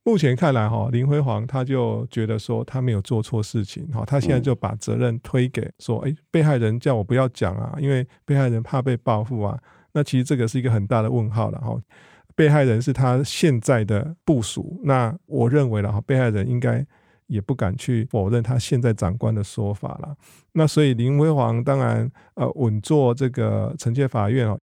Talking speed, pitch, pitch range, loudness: 290 characters per minute, 125 Hz, 115-140 Hz, -22 LUFS